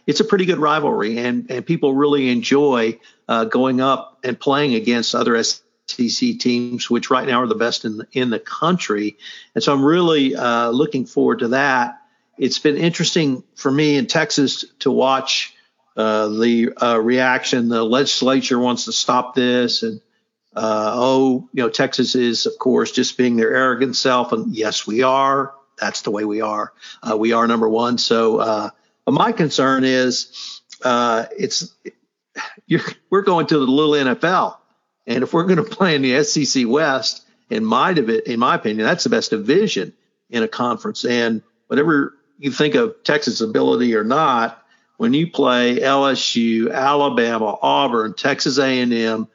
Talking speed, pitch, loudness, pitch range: 170 wpm, 130 Hz, -18 LUFS, 120-150 Hz